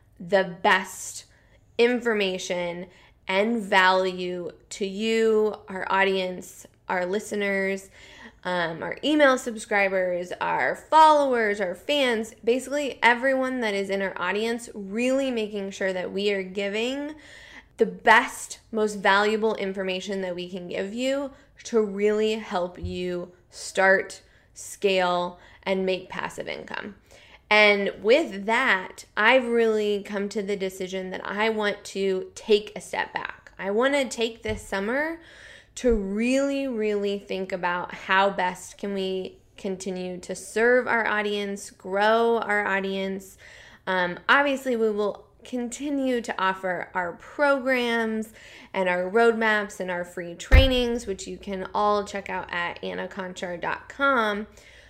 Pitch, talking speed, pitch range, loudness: 205 Hz, 130 wpm, 190-230 Hz, -25 LUFS